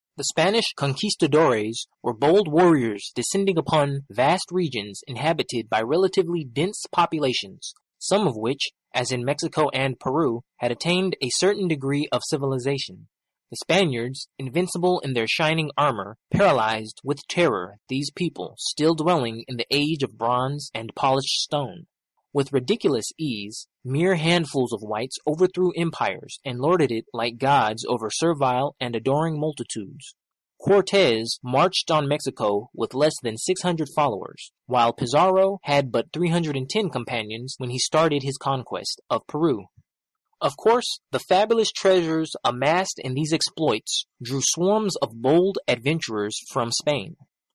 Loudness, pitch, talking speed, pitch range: -23 LUFS, 145 Hz, 140 wpm, 125-170 Hz